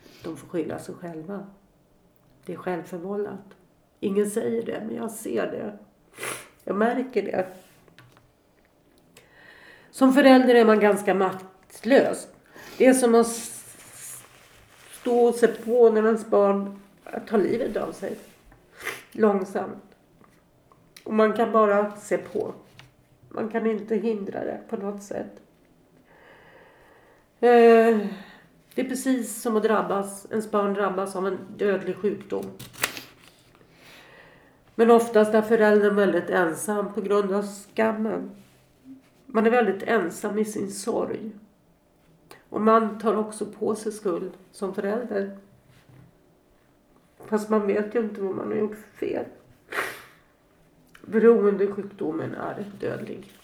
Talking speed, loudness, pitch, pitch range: 120 wpm, -24 LUFS, 210 Hz, 200-225 Hz